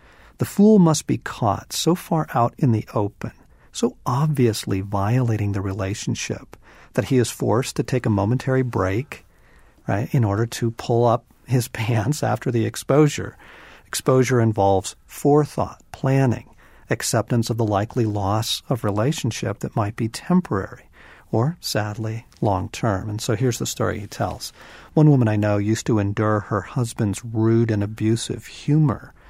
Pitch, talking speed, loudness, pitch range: 115 Hz, 155 wpm, -22 LUFS, 105-130 Hz